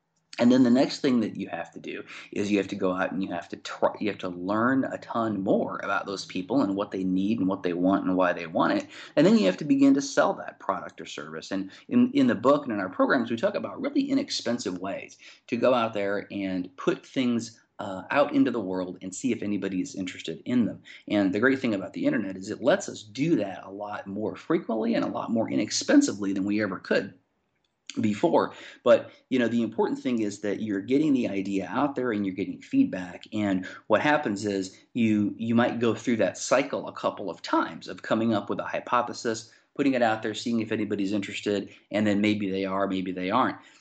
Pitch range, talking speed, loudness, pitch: 100-140 Hz, 235 wpm, -27 LUFS, 105 Hz